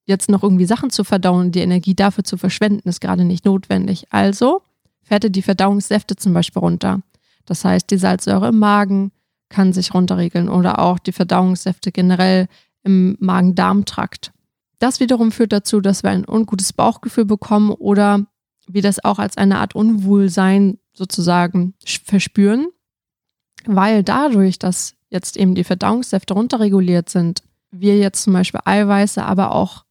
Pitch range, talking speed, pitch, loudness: 185-205 Hz, 150 wpm, 195 Hz, -16 LUFS